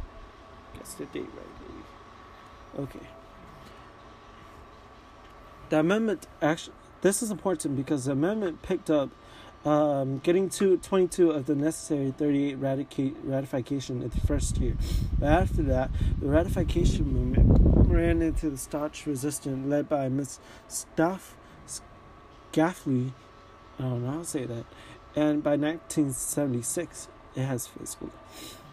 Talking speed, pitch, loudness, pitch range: 125 wpm, 145 Hz, -28 LUFS, 130-160 Hz